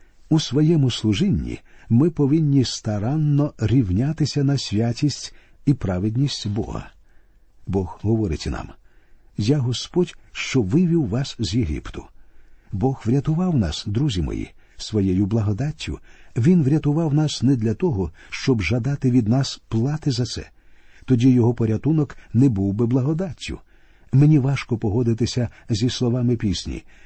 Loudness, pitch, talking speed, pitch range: -21 LUFS, 125 Hz, 120 wpm, 105-140 Hz